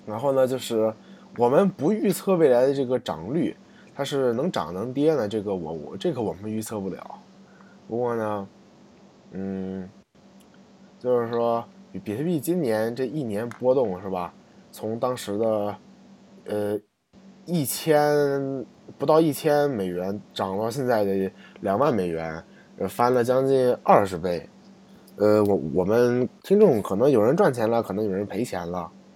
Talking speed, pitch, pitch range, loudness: 215 characters per minute, 120 Hz, 105-150 Hz, -24 LUFS